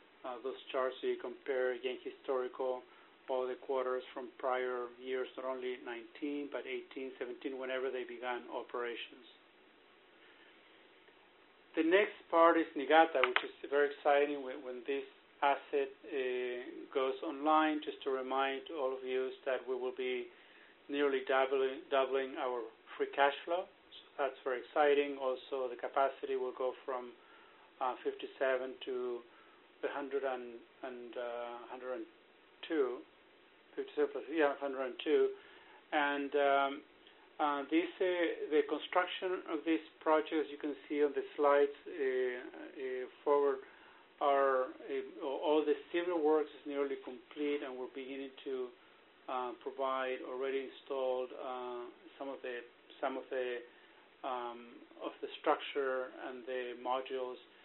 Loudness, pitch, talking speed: -37 LUFS, 145 Hz, 135 wpm